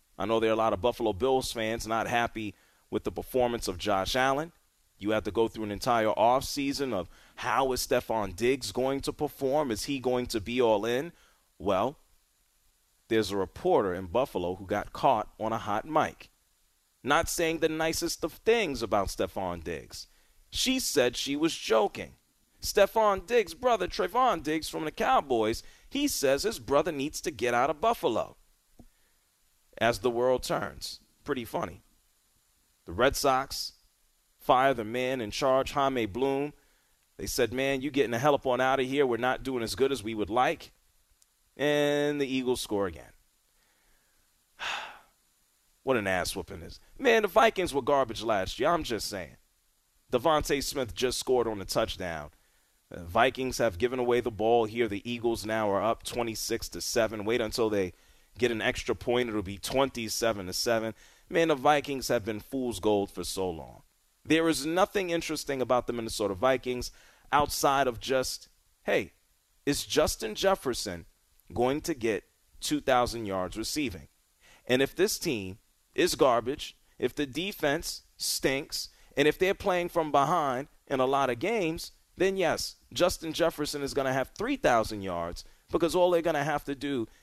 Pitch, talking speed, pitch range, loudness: 125 Hz, 170 wpm, 110-145 Hz, -29 LUFS